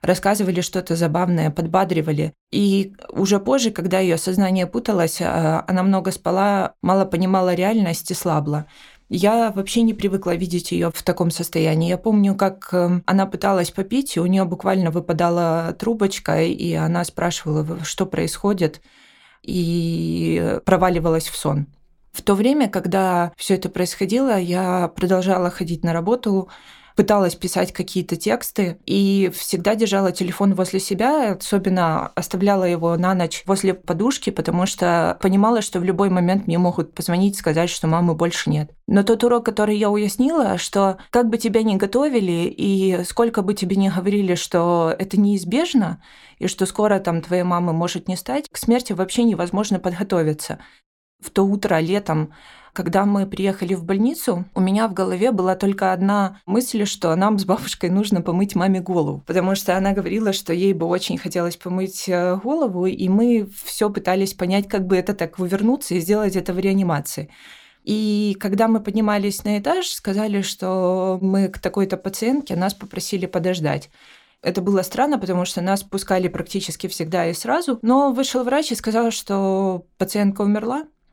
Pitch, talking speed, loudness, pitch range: 190 Hz, 160 wpm, -20 LUFS, 175-205 Hz